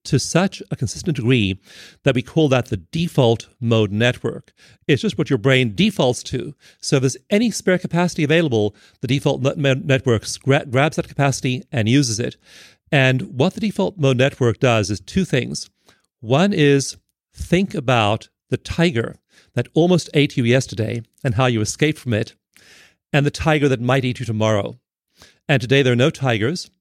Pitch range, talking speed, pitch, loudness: 120-155 Hz, 170 wpm, 135 Hz, -19 LUFS